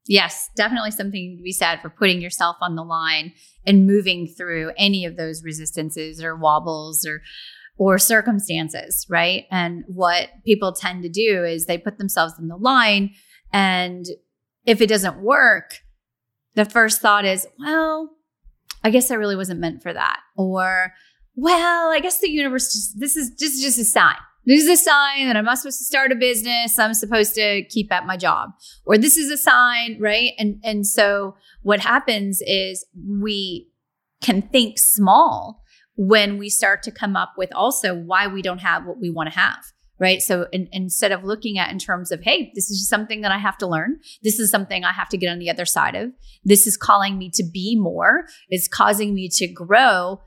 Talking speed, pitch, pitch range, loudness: 195 wpm, 200 Hz, 180-230 Hz, -18 LUFS